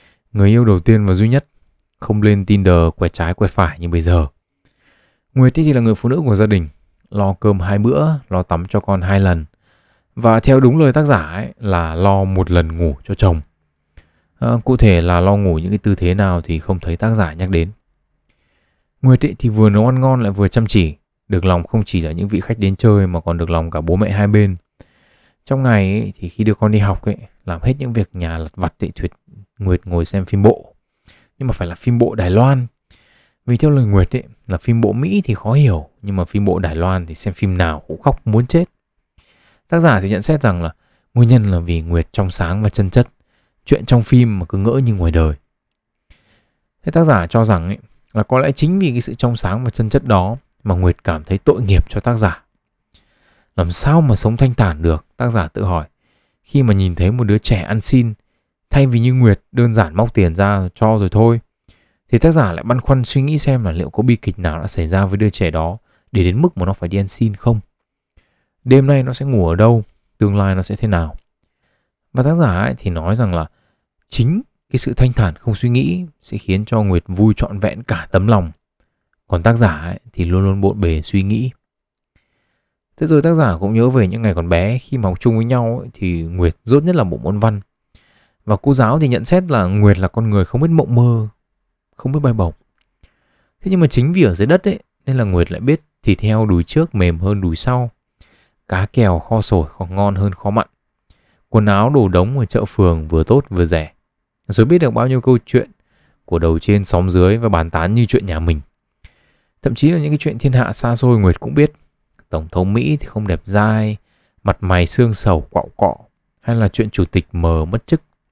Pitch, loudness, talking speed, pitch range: 105 Hz, -15 LUFS, 235 wpm, 90-120 Hz